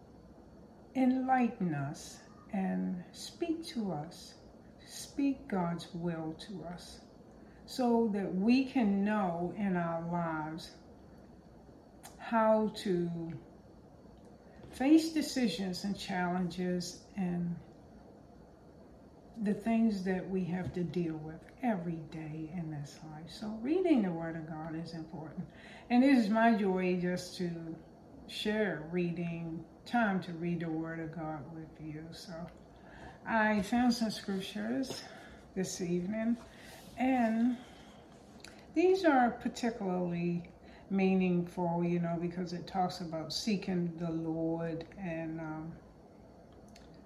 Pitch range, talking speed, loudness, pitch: 165-225 Hz, 110 wpm, -34 LUFS, 180 Hz